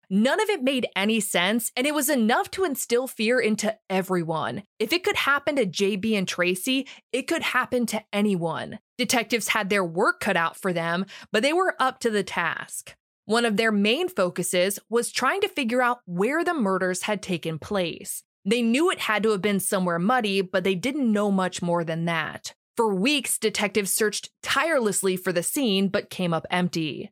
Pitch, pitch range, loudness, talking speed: 215 Hz, 190-245 Hz, -24 LUFS, 195 wpm